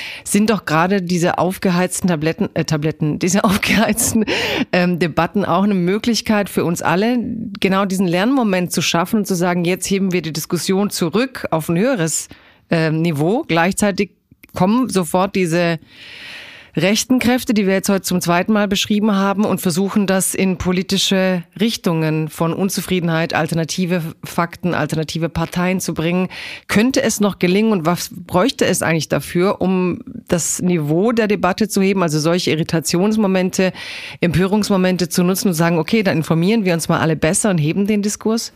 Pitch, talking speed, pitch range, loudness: 185 Hz, 160 wpm, 170-205 Hz, -17 LUFS